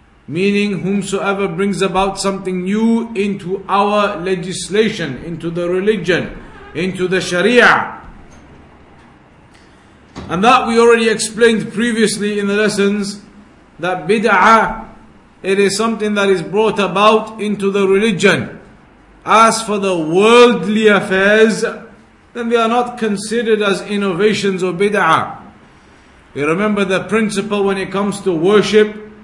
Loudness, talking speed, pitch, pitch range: -14 LUFS, 120 wpm, 200 Hz, 190-215 Hz